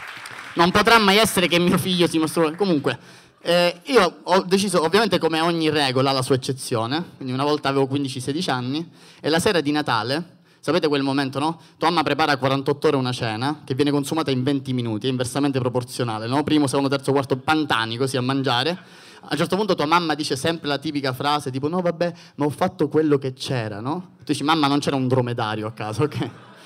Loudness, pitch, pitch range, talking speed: -21 LUFS, 145 Hz, 135-165 Hz, 215 wpm